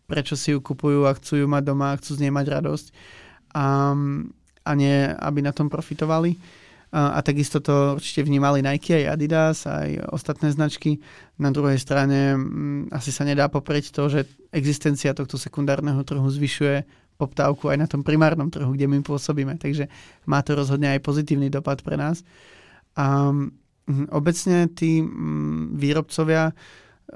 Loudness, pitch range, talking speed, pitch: -23 LUFS, 140-150 Hz, 160 wpm, 145 Hz